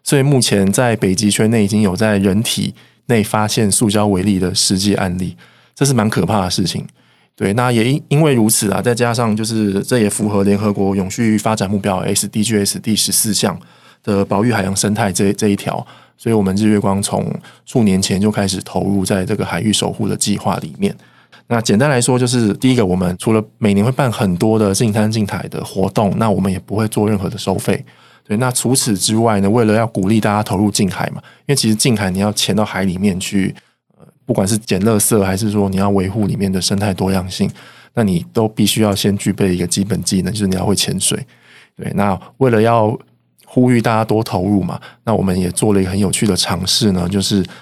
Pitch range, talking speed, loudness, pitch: 100-110 Hz, 320 characters per minute, -15 LUFS, 105 Hz